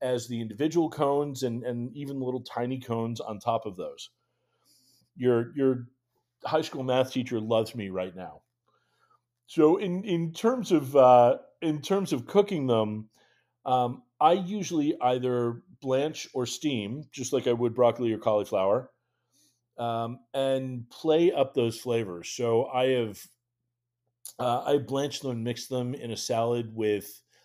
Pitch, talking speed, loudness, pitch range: 125 Hz, 150 wpm, -28 LUFS, 115-140 Hz